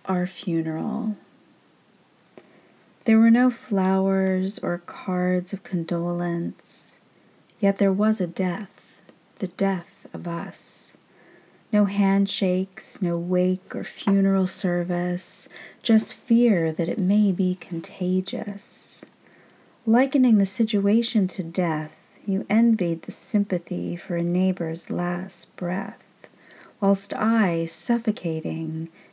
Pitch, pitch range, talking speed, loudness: 190 Hz, 175-210 Hz, 105 wpm, -24 LUFS